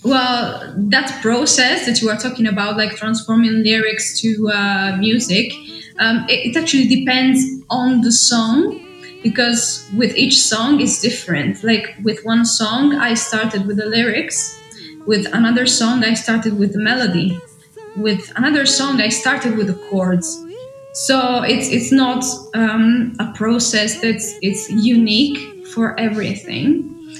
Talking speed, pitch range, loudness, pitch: 145 wpm, 215-255 Hz, -15 LUFS, 230 Hz